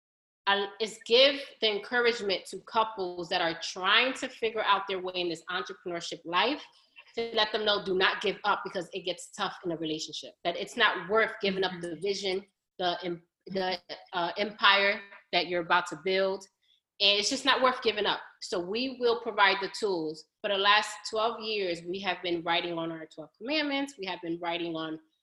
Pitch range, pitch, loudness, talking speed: 175-215 Hz, 195 Hz, -29 LUFS, 195 wpm